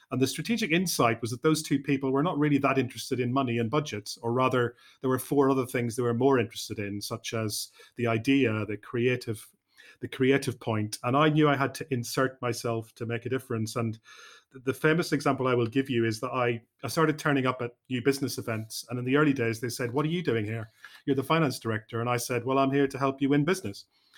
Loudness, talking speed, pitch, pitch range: -28 LUFS, 240 wpm, 130 Hz, 115-140 Hz